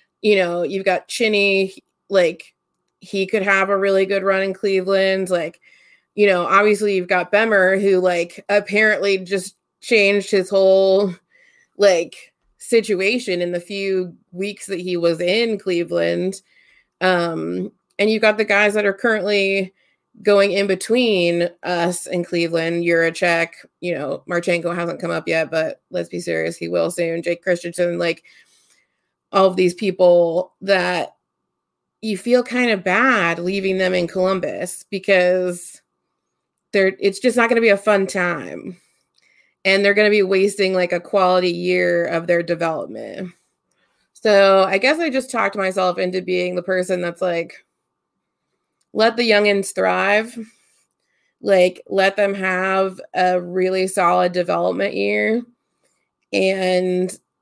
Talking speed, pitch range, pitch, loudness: 145 wpm, 175-200 Hz, 190 Hz, -18 LUFS